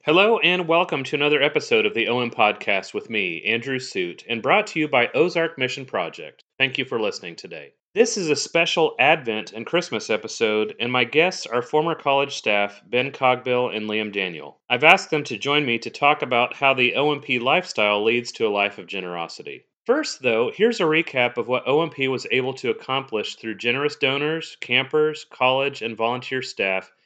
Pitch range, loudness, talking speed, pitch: 120-165 Hz, -21 LUFS, 190 wpm, 135 Hz